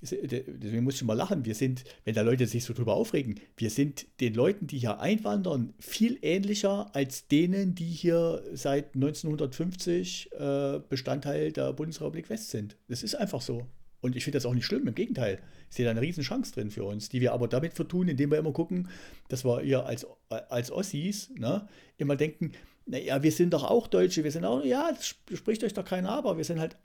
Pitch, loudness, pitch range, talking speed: 150 Hz, -30 LUFS, 125-180 Hz, 205 wpm